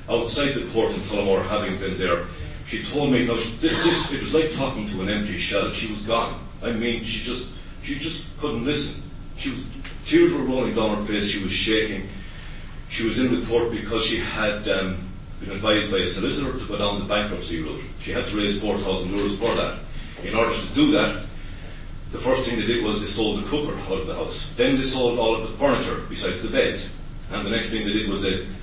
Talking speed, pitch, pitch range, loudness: 230 wpm, 105 Hz, 95-120 Hz, -23 LUFS